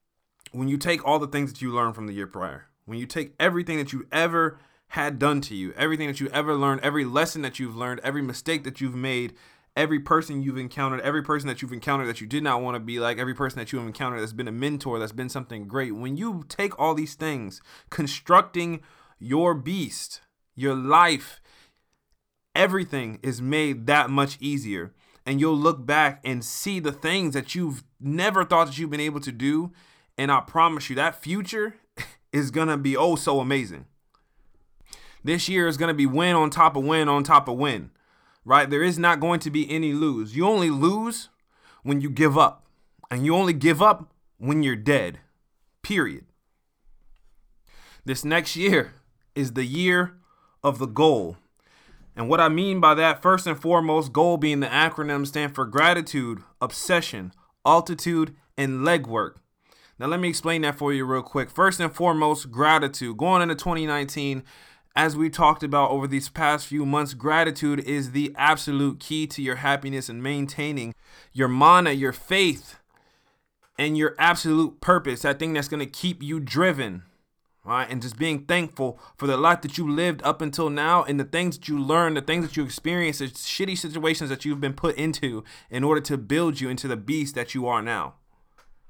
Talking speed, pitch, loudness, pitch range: 190 wpm, 145 Hz, -24 LUFS, 135-165 Hz